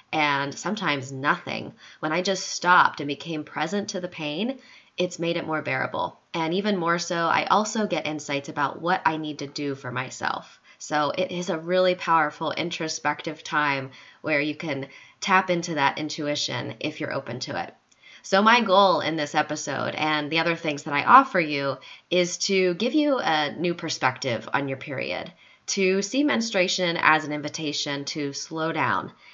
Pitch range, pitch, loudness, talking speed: 145-185 Hz, 160 Hz, -24 LUFS, 180 wpm